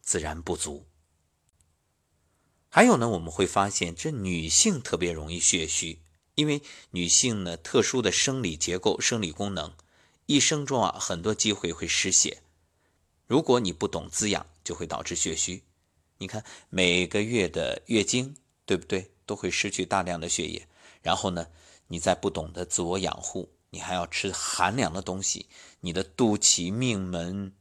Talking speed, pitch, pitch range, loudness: 235 characters per minute, 90 Hz, 85-100 Hz, -26 LUFS